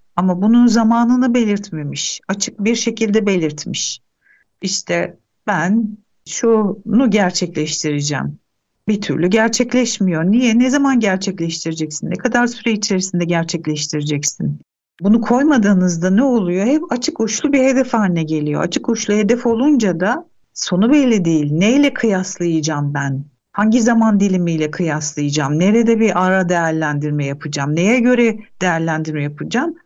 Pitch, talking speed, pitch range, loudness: 195 Hz, 120 wpm, 160-230 Hz, -16 LUFS